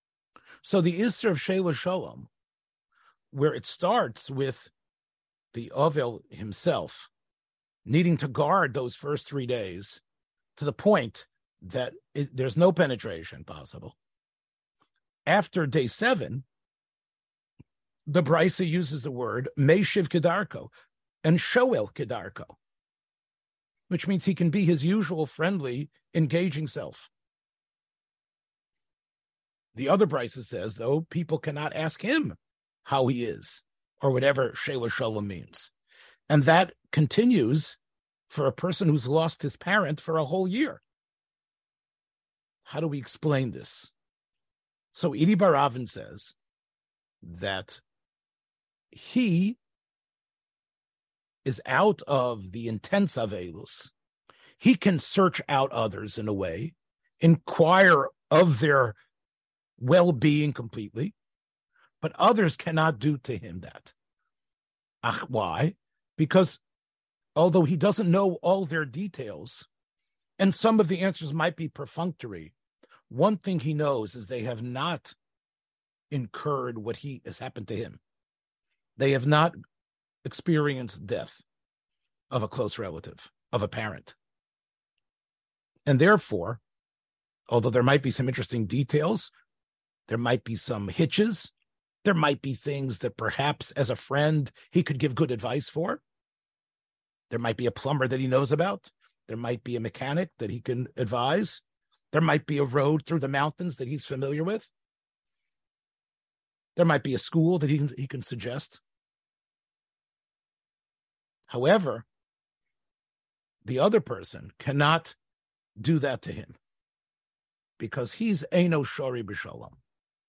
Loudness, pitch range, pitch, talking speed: -27 LUFS, 130-175 Hz, 150 Hz, 125 wpm